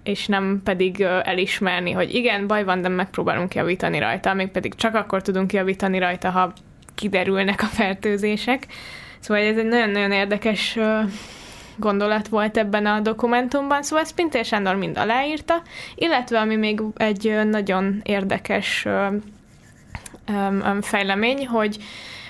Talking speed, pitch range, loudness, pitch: 125 wpm, 195-220 Hz, -21 LUFS, 210 Hz